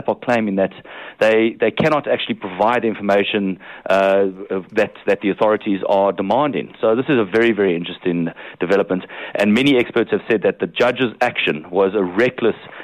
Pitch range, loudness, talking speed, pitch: 95-115 Hz, -18 LUFS, 170 wpm, 100 Hz